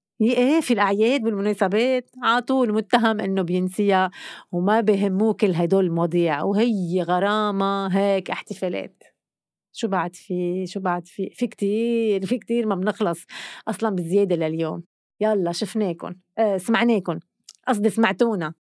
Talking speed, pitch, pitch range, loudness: 125 wpm, 205 Hz, 185-225 Hz, -22 LUFS